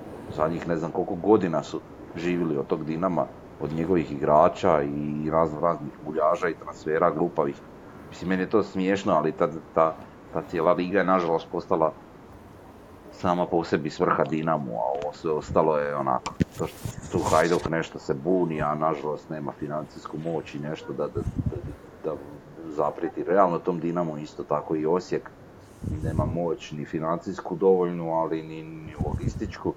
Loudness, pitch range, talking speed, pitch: -26 LUFS, 75-90 Hz, 160 wpm, 80 Hz